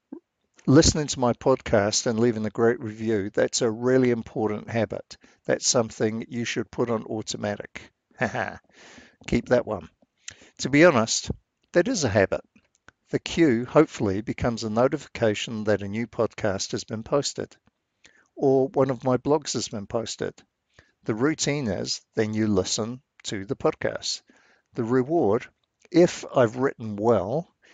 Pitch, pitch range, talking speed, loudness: 120 Hz, 110-130 Hz, 145 wpm, -25 LUFS